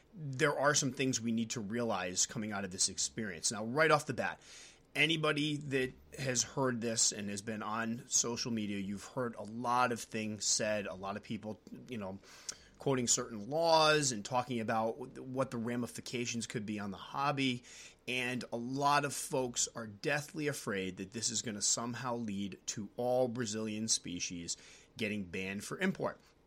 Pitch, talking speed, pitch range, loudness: 120 Hz, 180 wpm, 105-130 Hz, -35 LUFS